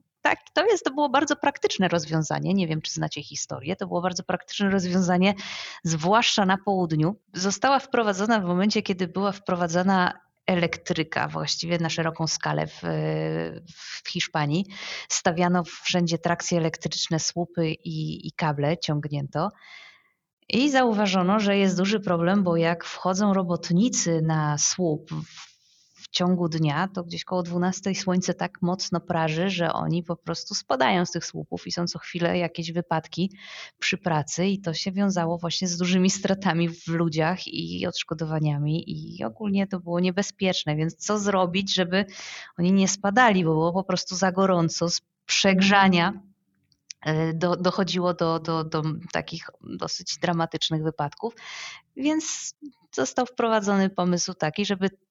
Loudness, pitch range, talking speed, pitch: -25 LUFS, 165-195 Hz, 140 wpm, 180 Hz